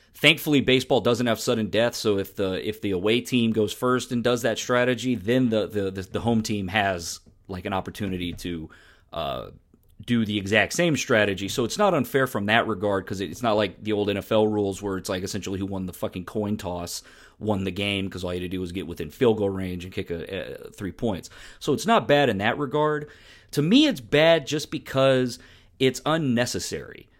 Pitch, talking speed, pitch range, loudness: 105 Hz, 215 wpm, 95-125 Hz, -24 LUFS